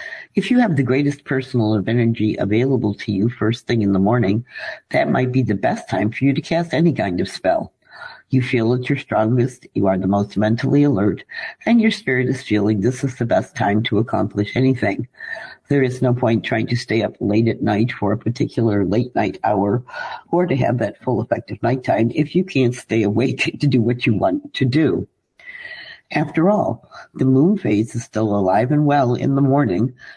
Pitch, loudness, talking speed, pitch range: 120 Hz, -19 LUFS, 205 wpm, 110-140 Hz